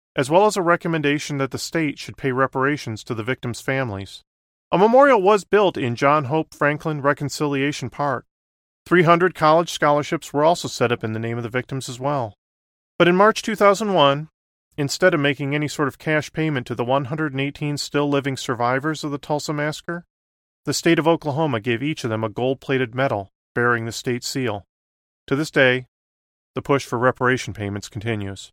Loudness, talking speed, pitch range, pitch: -21 LUFS, 185 wpm, 120-155 Hz, 140 Hz